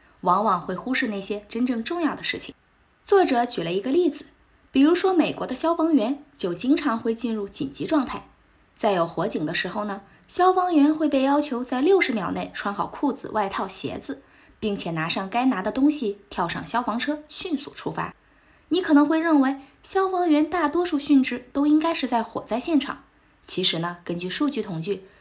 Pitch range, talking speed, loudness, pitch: 210-305 Hz, 285 characters per minute, -23 LUFS, 270 Hz